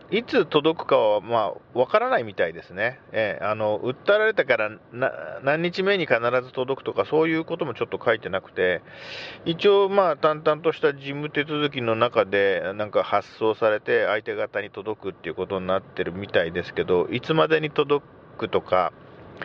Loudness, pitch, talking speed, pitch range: -24 LUFS, 150 Hz, 300 characters per minute, 120-190 Hz